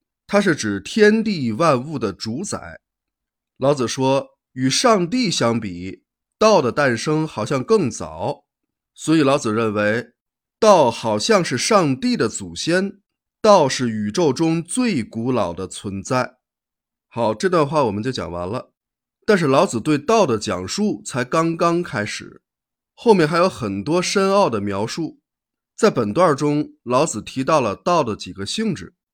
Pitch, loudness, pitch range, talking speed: 135 Hz, -19 LUFS, 110-175 Hz, 210 characters per minute